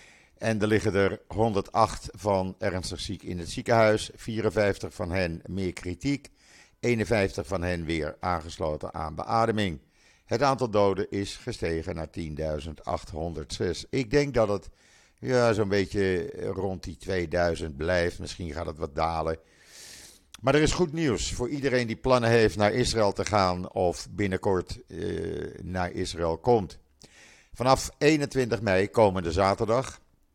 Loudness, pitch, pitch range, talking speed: -27 LUFS, 95 Hz, 85-115 Hz, 140 wpm